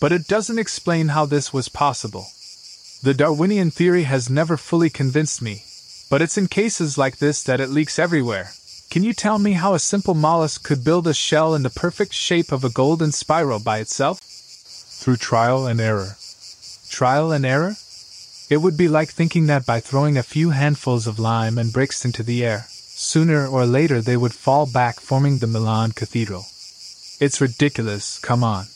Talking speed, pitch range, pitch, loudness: 185 wpm, 120-160 Hz, 140 Hz, -19 LUFS